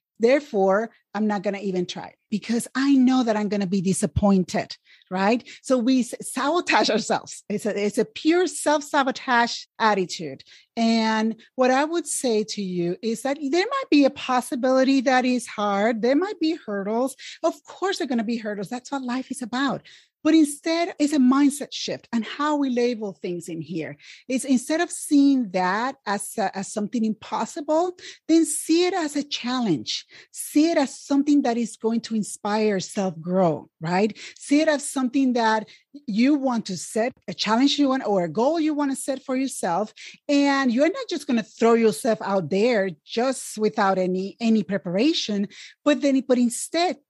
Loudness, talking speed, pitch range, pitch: -23 LUFS, 185 wpm, 210-285 Hz, 245 Hz